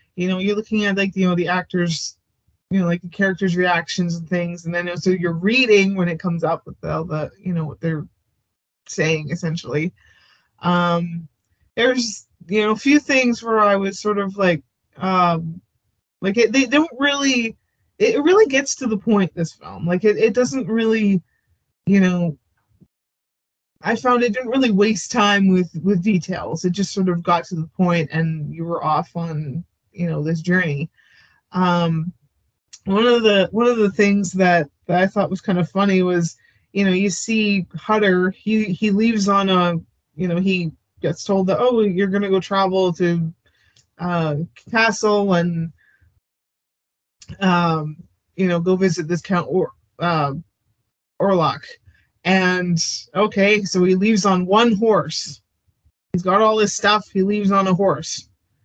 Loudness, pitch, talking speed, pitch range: -19 LUFS, 180 Hz, 170 wpm, 165-205 Hz